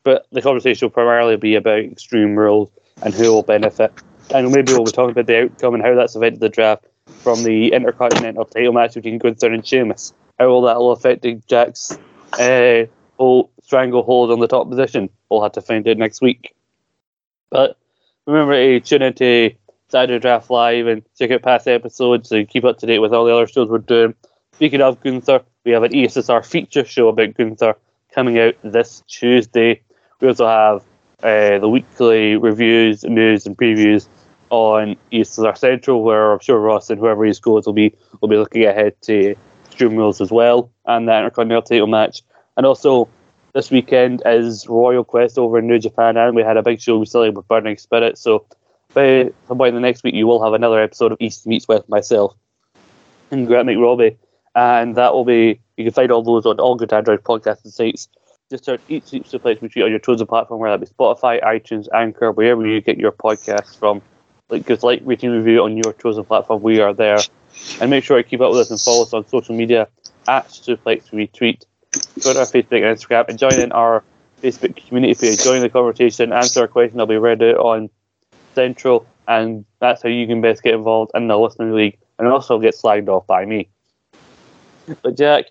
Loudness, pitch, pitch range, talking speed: -15 LUFS, 115 Hz, 110-120 Hz, 200 wpm